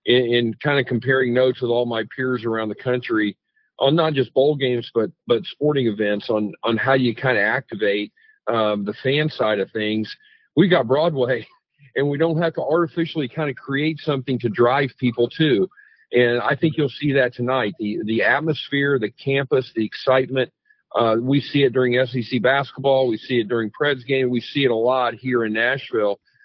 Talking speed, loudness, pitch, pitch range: 195 wpm, -20 LUFS, 130 Hz, 120-145 Hz